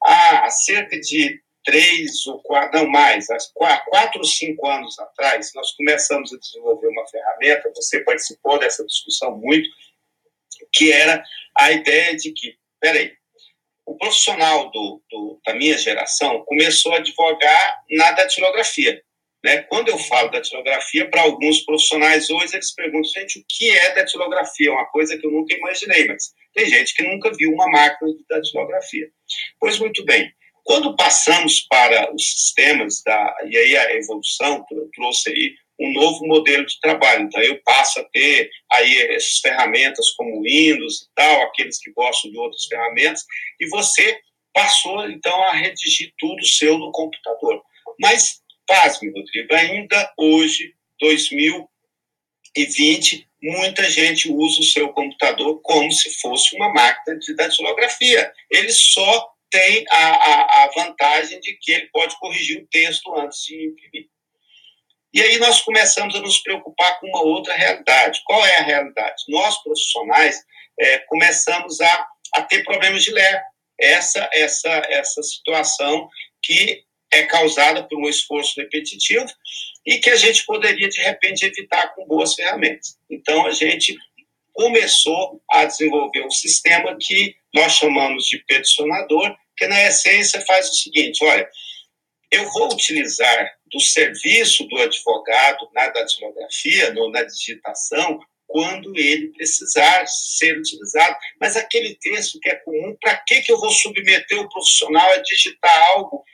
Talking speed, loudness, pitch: 150 wpm, -15 LUFS, 195 Hz